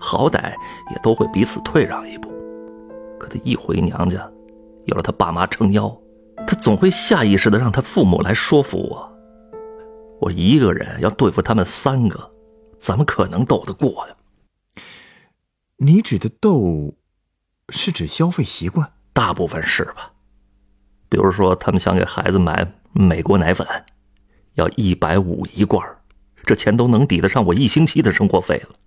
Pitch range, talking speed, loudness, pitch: 100-160 Hz, 225 characters per minute, -18 LUFS, 110 Hz